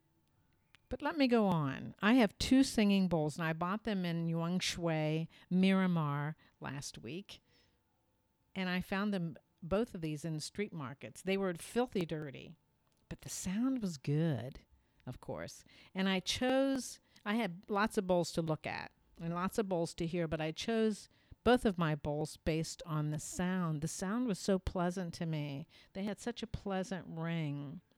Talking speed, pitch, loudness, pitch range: 175 wpm, 175 Hz, -36 LUFS, 155-200 Hz